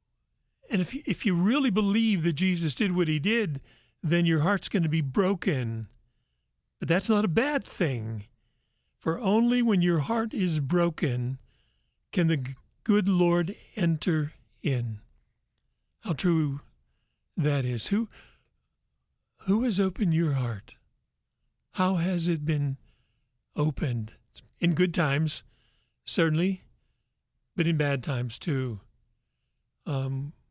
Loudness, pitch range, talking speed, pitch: -27 LUFS, 130-190 Hz, 120 wpm, 165 Hz